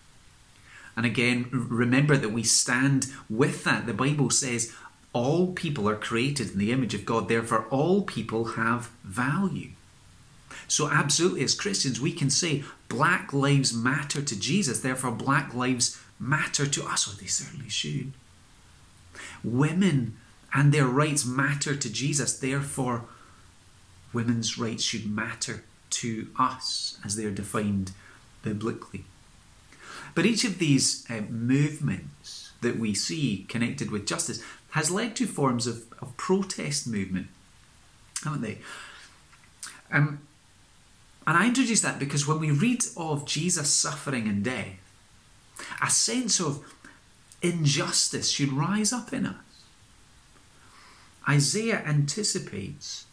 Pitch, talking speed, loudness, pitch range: 130 Hz, 130 wpm, -26 LUFS, 115-150 Hz